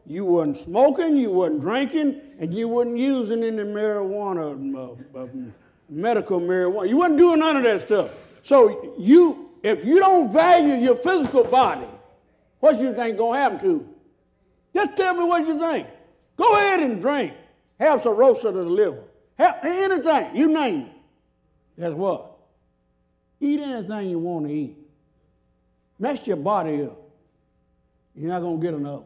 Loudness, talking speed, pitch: -21 LUFS, 160 wpm, 235 Hz